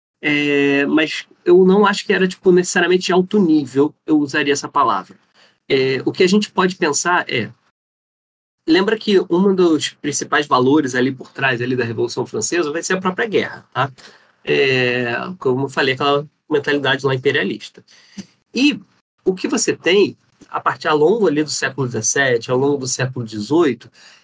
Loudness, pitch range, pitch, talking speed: -17 LUFS, 135-185 Hz, 150 Hz, 170 wpm